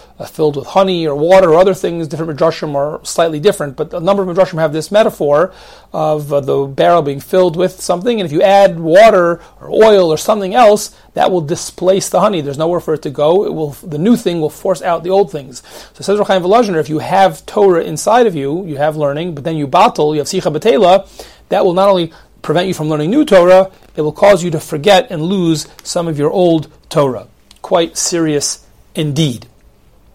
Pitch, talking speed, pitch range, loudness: 170 Hz, 215 wpm, 155-190 Hz, -13 LUFS